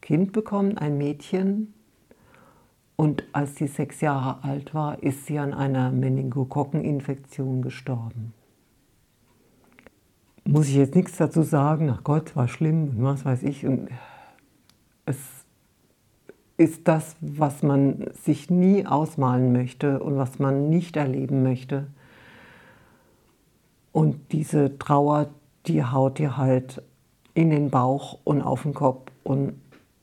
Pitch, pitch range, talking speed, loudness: 145 Hz, 130-155 Hz, 120 wpm, -24 LUFS